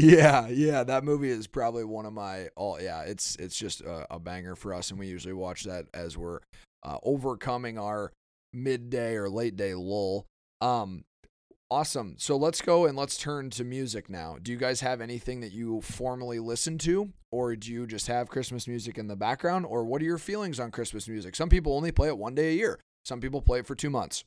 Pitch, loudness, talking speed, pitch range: 120 Hz, -30 LUFS, 225 wpm, 105-135 Hz